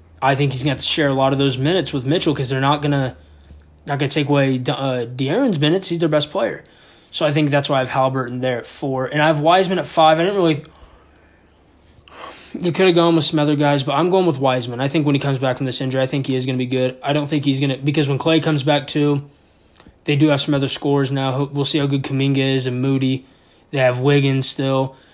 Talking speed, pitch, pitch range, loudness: 260 wpm, 140 Hz, 130-150 Hz, -18 LUFS